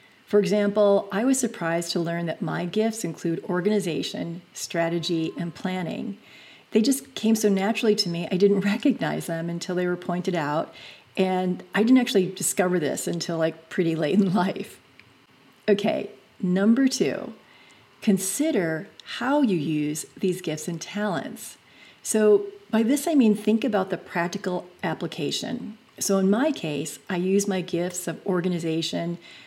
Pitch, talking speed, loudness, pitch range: 190 Hz, 150 wpm, -25 LUFS, 170-215 Hz